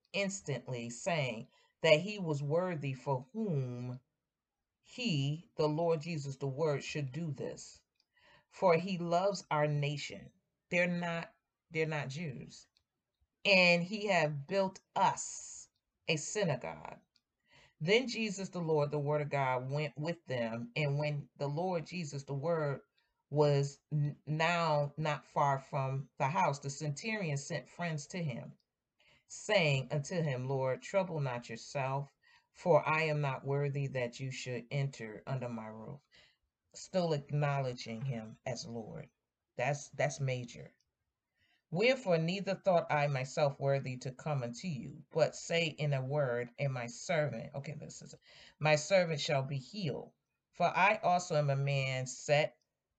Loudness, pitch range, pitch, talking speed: -35 LUFS, 135-165 Hz, 150 Hz, 140 wpm